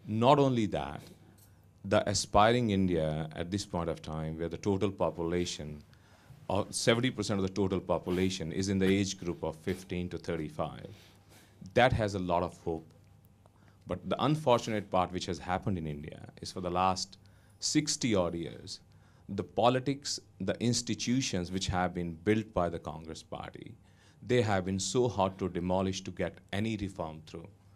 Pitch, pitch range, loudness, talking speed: 95 Hz, 85-105 Hz, -32 LUFS, 165 wpm